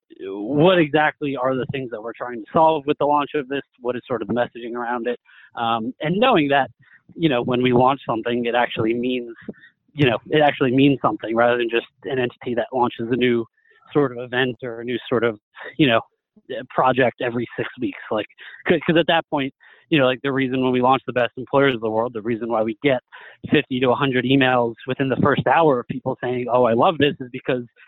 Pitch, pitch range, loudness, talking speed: 130 Hz, 120-145 Hz, -20 LUFS, 230 wpm